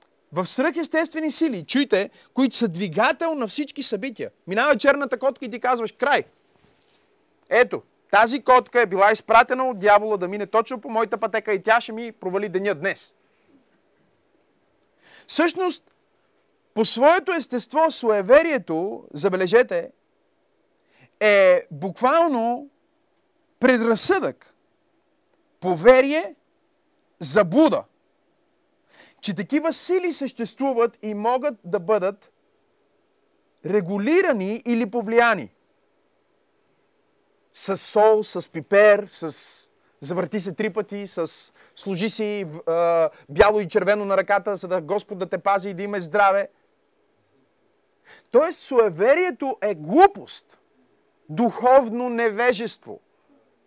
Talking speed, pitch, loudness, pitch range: 105 wpm, 235 Hz, -21 LUFS, 205-310 Hz